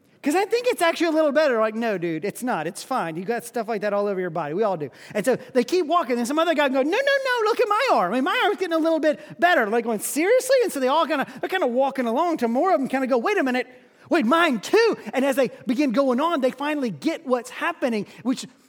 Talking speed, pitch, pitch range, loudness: 295 wpm, 270 Hz, 240-335 Hz, -22 LUFS